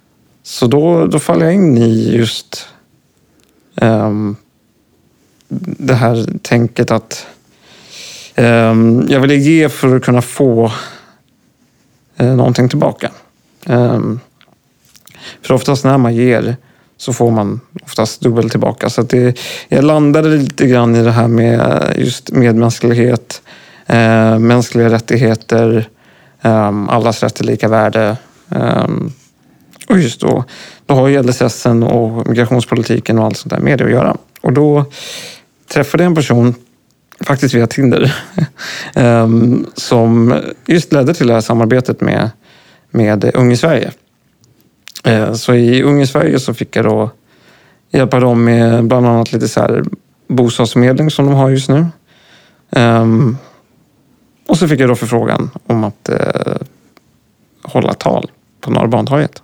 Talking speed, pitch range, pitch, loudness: 135 wpm, 115-135 Hz, 120 Hz, -12 LUFS